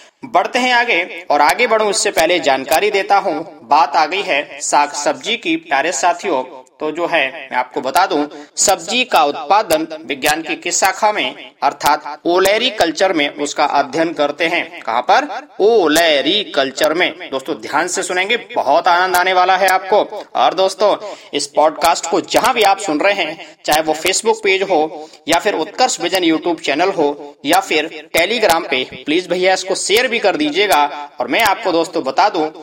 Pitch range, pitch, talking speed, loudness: 155-205 Hz, 180 Hz, 180 wpm, -15 LUFS